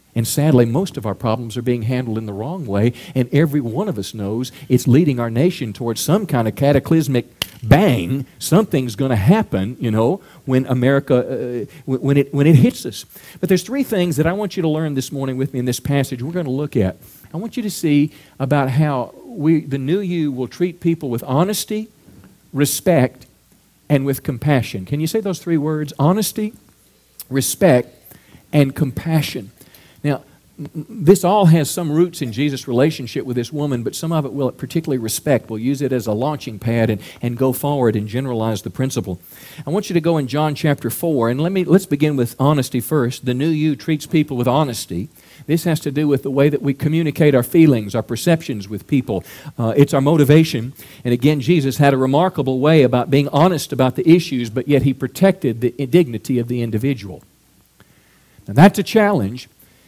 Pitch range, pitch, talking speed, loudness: 125-155 Hz, 140 Hz, 200 wpm, -18 LUFS